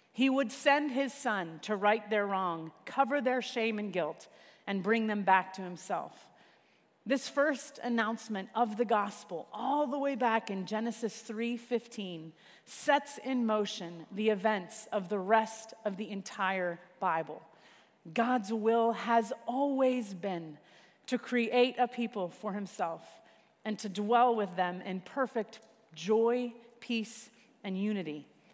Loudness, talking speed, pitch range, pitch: -32 LUFS, 140 wpm, 200-245 Hz, 220 Hz